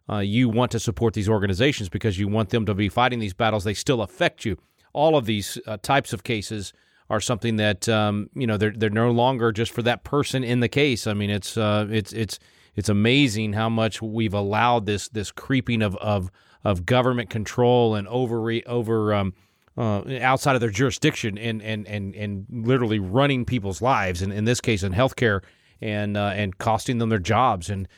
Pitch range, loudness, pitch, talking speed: 105-120 Hz, -23 LUFS, 110 Hz, 205 wpm